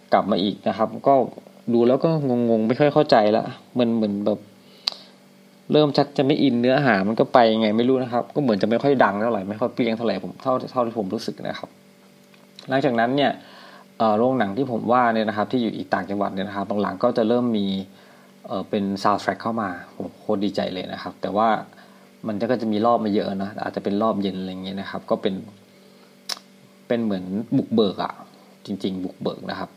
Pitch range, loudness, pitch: 100-125 Hz, -22 LUFS, 110 Hz